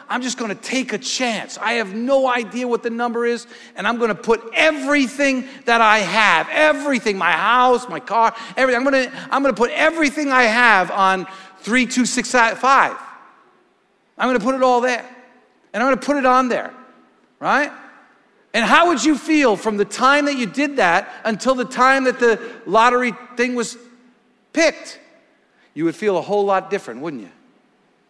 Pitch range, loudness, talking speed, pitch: 230-270 Hz, -17 LUFS, 195 wpm, 245 Hz